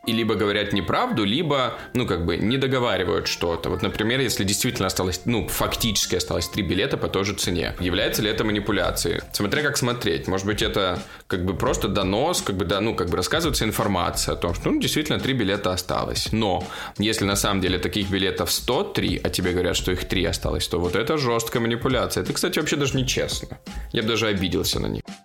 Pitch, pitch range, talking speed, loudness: 105 Hz, 95-115 Hz, 205 wpm, -23 LUFS